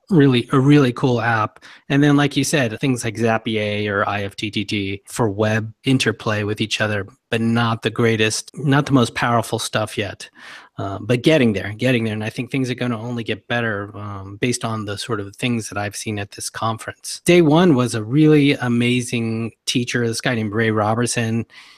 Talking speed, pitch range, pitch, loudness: 200 wpm, 110-125 Hz, 115 Hz, -19 LUFS